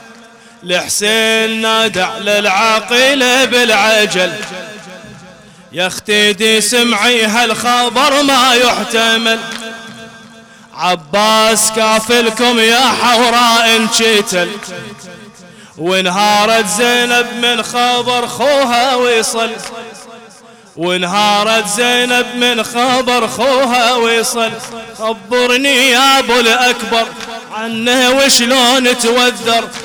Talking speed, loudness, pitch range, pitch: 70 wpm, -10 LUFS, 220-245 Hz, 230 Hz